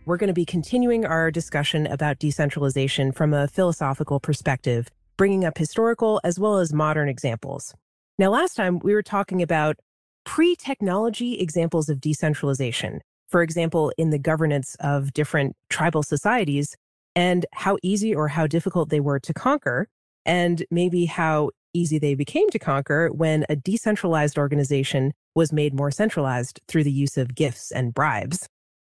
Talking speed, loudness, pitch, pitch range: 155 wpm, -23 LUFS, 155 Hz, 145-180 Hz